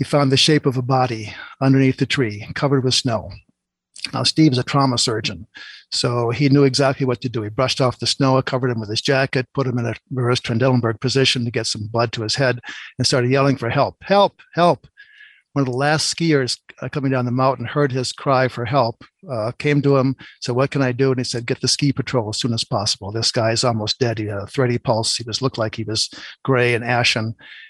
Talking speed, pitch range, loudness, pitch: 235 wpm, 115-135 Hz, -19 LUFS, 130 Hz